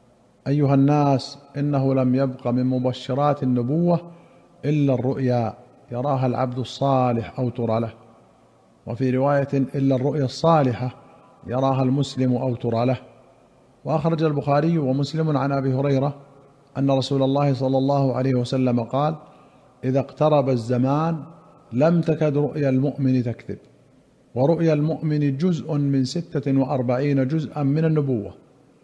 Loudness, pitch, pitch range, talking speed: -22 LUFS, 135 Hz, 125-145 Hz, 120 wpm